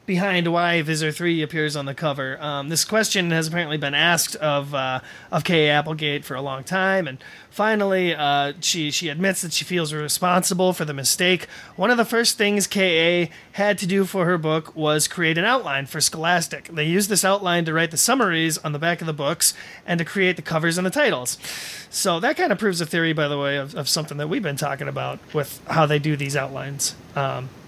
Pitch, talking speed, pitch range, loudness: 165 Hz, 220 wpm, 150-185 Hz, -21 LUFS